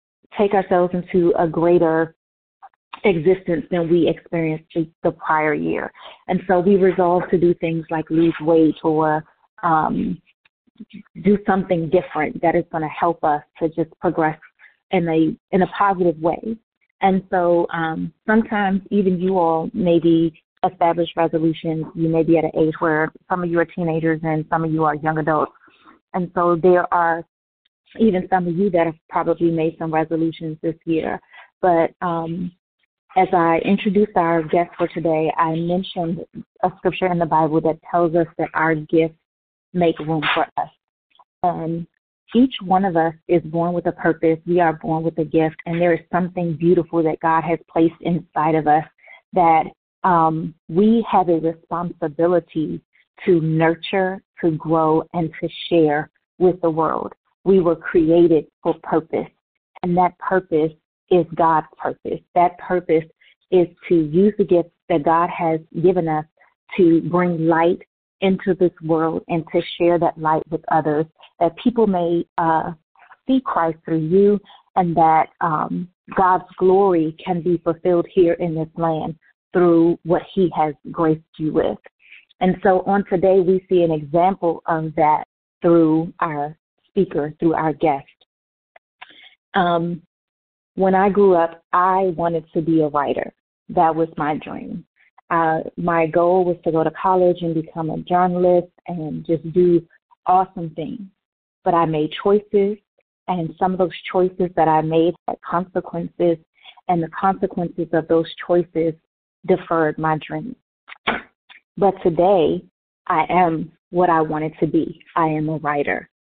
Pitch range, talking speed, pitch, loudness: 160-180 Hz, 160 wpm, 170 Hz, -19 LUFS